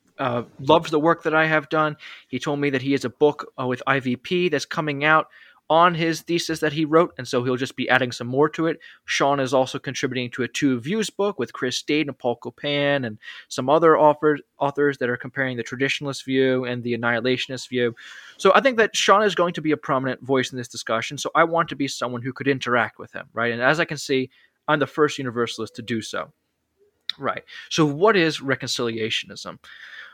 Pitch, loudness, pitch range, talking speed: 140 Hz, -22 LUFS, 125-155 Hz, 220 wpm